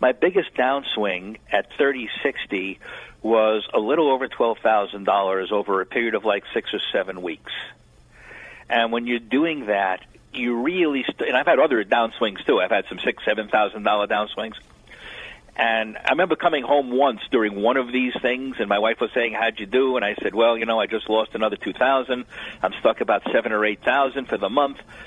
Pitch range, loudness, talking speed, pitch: 105-130 Hz, -22 LUFS, 205 wpm, 115 Hz